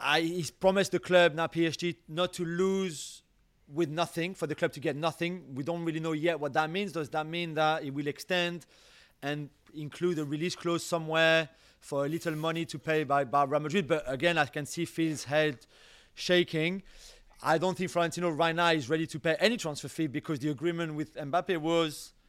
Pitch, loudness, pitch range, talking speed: 165 Hz, -30 LUFS, 155-175 Hz, 200 wpm